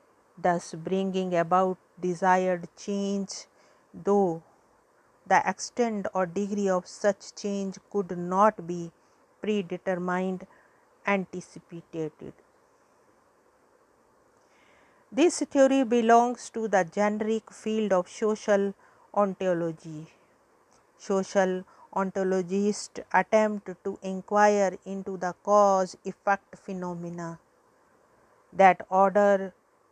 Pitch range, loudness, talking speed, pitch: 185-215 Hz, -27 LUFS, 80 wpm, 195 Hz